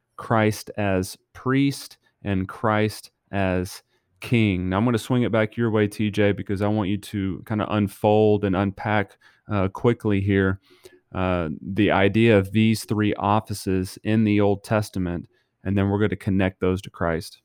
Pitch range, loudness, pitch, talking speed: 95-110 Hz, -23 LUFS, 105 Hz, 170 wpm